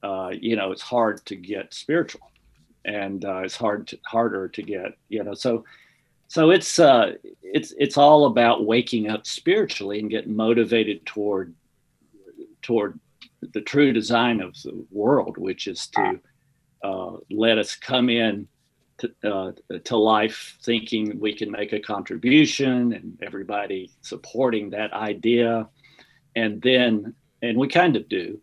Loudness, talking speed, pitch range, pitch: -22 LUFS, 150 wpm, 105-130 Hz, 115 Hz